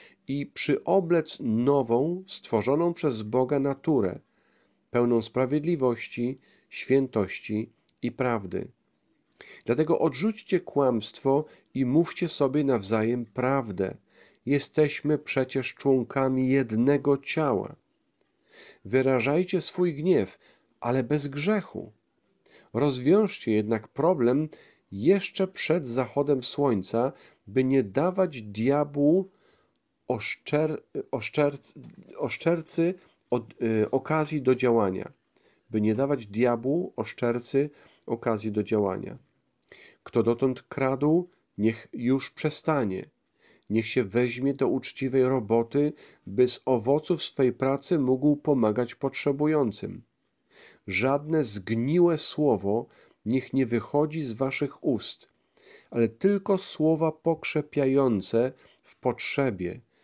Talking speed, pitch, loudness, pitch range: 95 wpm, 135 Hz, -27 LUFS, 120-150 Hz